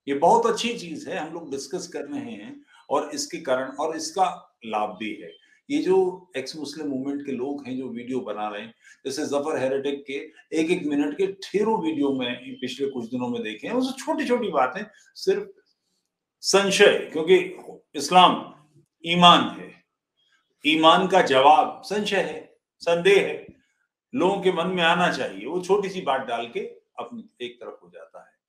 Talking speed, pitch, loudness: 175 wpm, 180 Hz, -23 LUFS